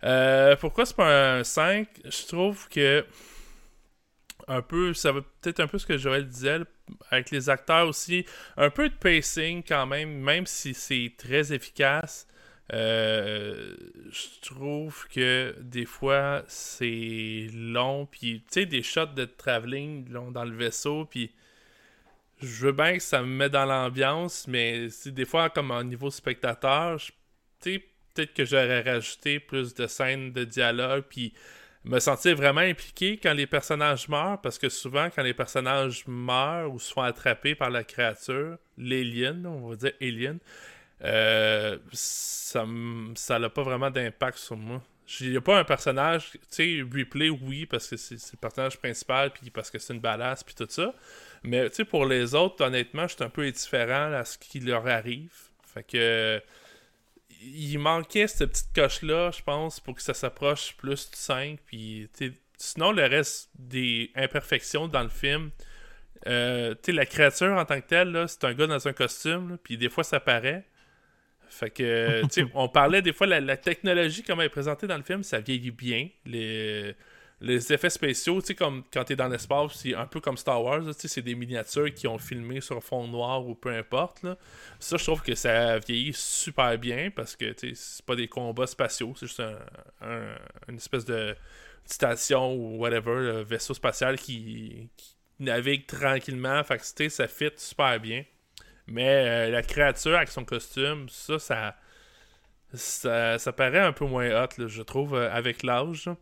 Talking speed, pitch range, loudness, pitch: 180 wpm, 120-150 Hz, -27 LUFS, 135 Hz